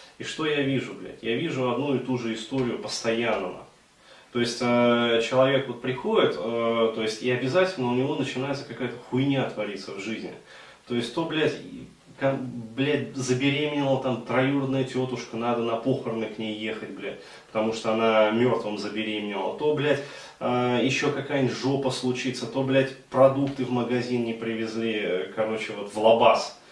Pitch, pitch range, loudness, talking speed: 125 Hz, 115-135 Hz, -26 LUFS, 160 wpm